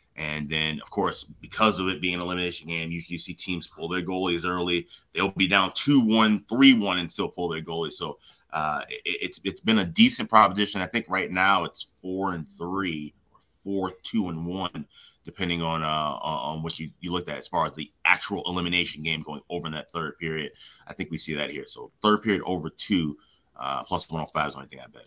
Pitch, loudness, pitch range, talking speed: 90 Hz, -26 LUFS, 80-95 Hz, 230 wpm